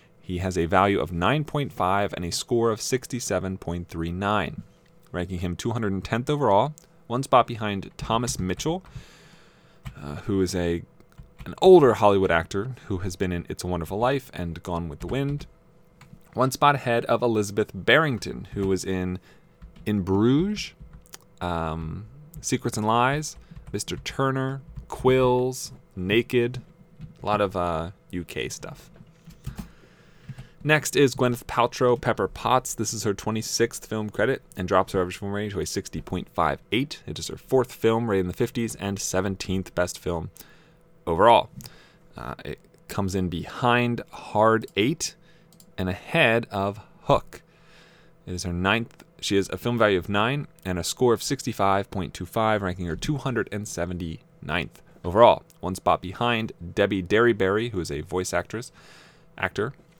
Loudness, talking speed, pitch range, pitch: -25 LUFS, 145 wpm, 95-130 Hz, 110 Hz